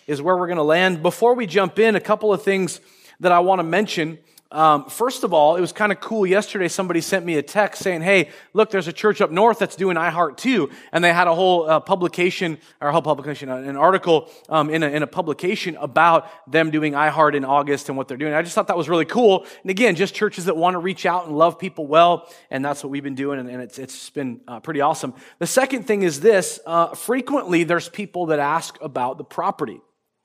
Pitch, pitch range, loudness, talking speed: 175 Hz, 155-195 Hz, -19 LUFS, 245 wpm